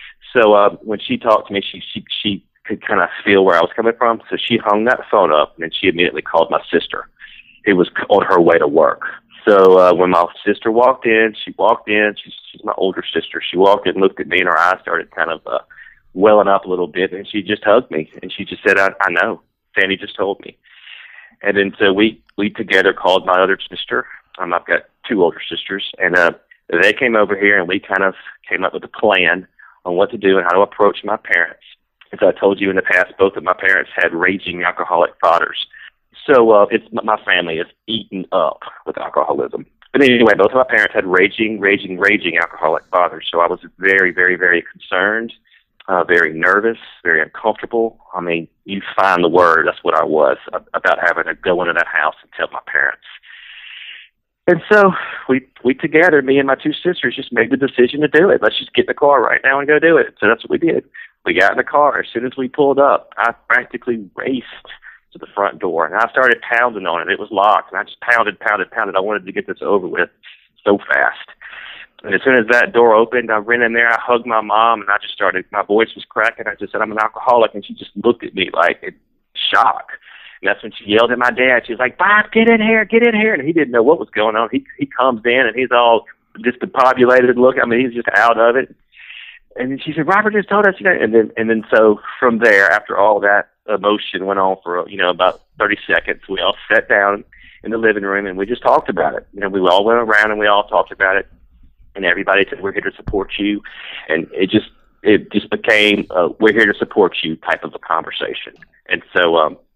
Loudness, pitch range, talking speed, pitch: -15 LUFS, 100-130 Hz, 240 wpm, 110 Hz